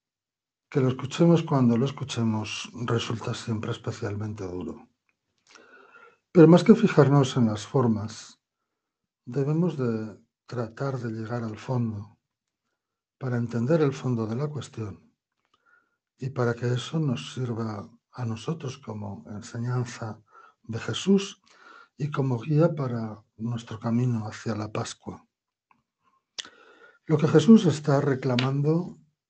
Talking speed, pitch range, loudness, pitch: 115 wpm, 115-155 Hz, -25 LUFS, 125 Hz